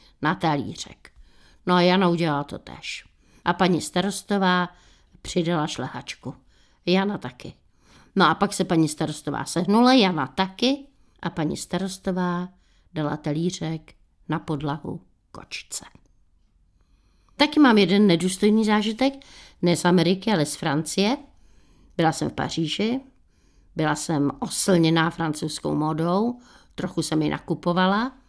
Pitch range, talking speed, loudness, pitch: 155-200 Hz, 120 wpm, -23 LUFS, 175 Hz